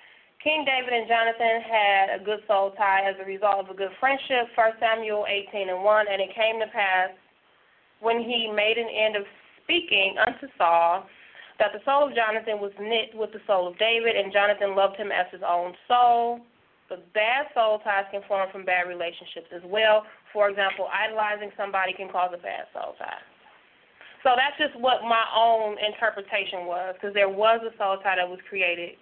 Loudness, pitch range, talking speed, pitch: -24 LUFS, 195-230 Hz, 190 wpm, 210 Hz